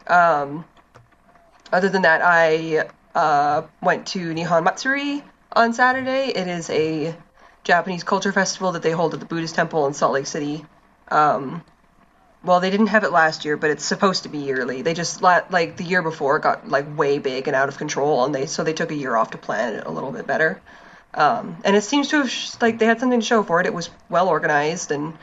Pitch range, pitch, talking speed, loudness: 155-200 Hz, 170 Hz, 220 wpm, -20 LUFS